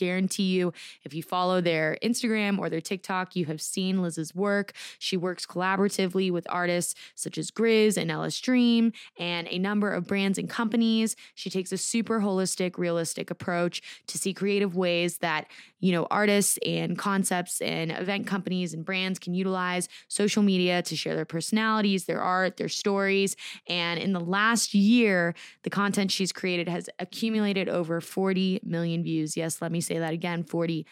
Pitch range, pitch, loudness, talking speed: 170-200 Hz, 185 Hz, -27 LUFS, 175 wpm